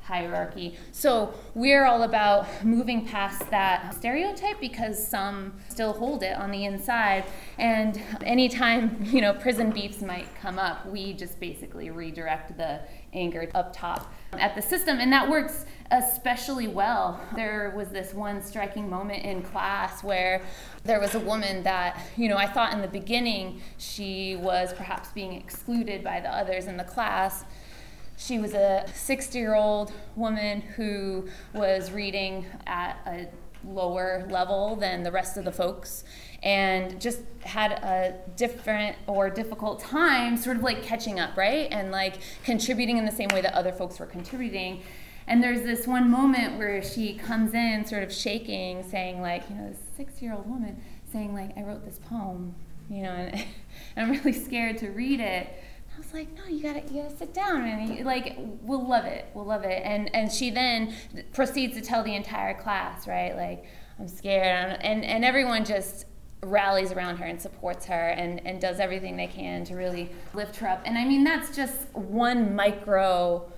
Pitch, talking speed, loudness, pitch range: 205 Hz, 175 wpm, -27 LUFS, 185-235 Hz